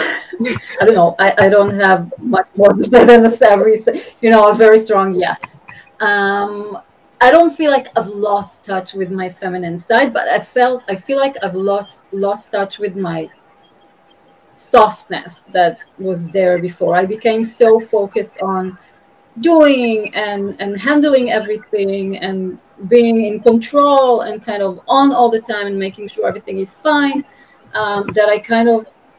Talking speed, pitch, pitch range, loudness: 165 wpm, 210 Hz, 195-230 Hz, -13 LUFS